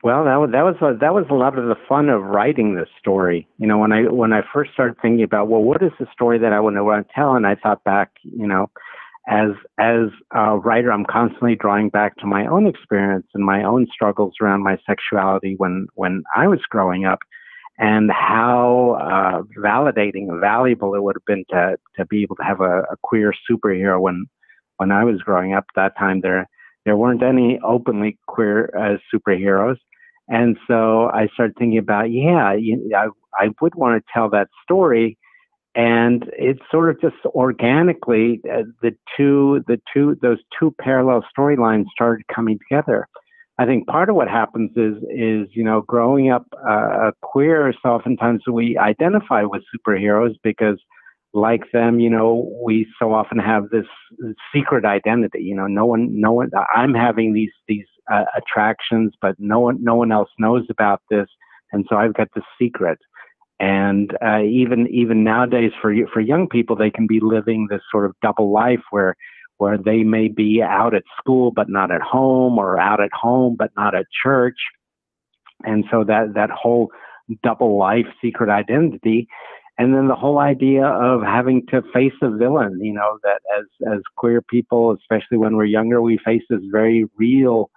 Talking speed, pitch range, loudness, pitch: 185 wpm, 105-120 Hz, -18 LUFS, 115 Hz